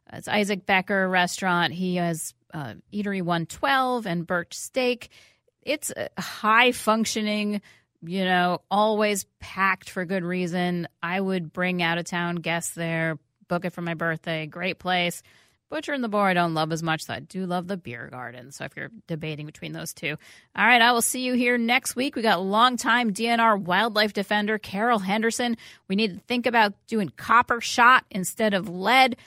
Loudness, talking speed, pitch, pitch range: -24 LUFS, 180 wpm, 190 Hz, 170-225 Hz